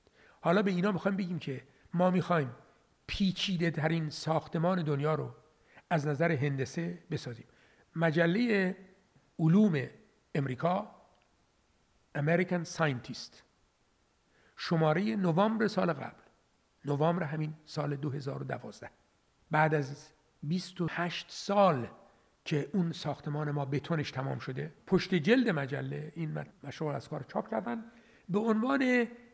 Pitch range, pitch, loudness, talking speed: 150-185 Hz, 165 Hz, -32 LUFS, 105 wpm